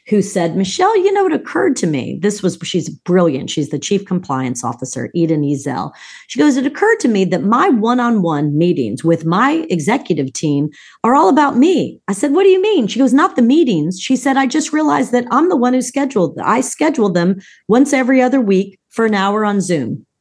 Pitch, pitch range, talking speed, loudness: 210 Hz, 175-275 Hz, 215 wpm, -15 LUFS